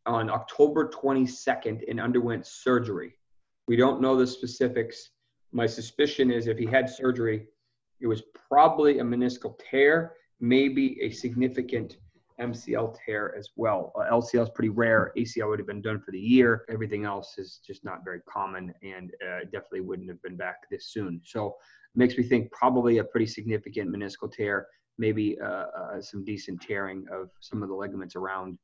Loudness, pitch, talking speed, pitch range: -27 LUFS, 115 Hz, 175 wpm, 105-125 Hz